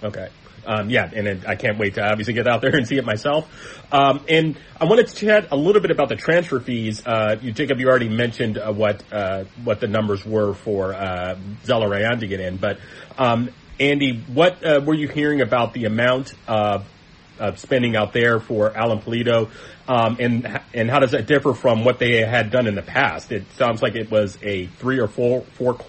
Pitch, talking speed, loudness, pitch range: 120 Hz, 215 wpm, -20 LUFS, 105-135 Hz